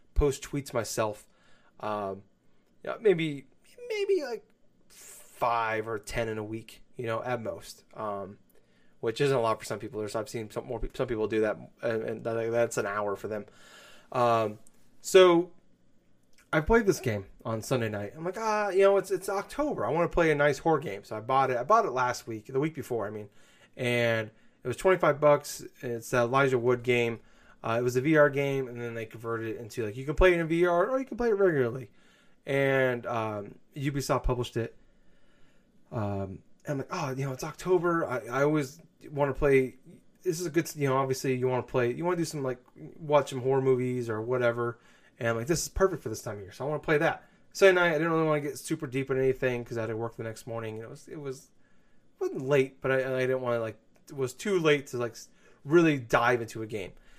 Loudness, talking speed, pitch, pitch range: -29 LUFS, 235 wpm, 130 Hz, 115-155 Hz